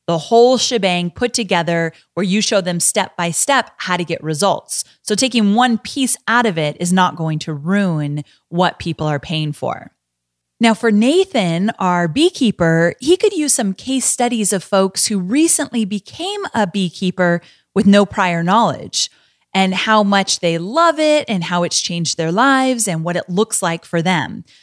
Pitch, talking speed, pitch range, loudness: 195 Hz, 180 wpm, 170-235 Hz, -16 LUFS